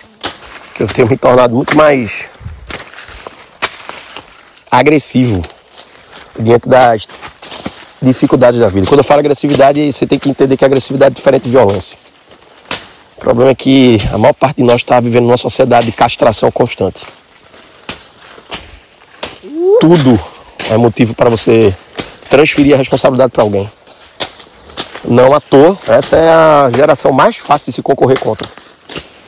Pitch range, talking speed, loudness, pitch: 120-140 Hz, 135 wpm, -9 LUFS, 130 Hz